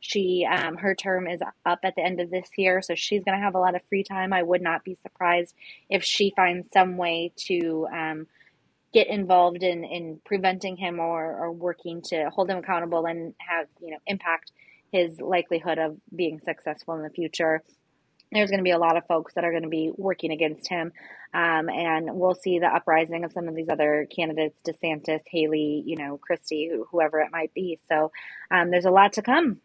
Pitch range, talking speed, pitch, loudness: 160-185 Hz, 210 wpm, 170 Hz, -25 LUFS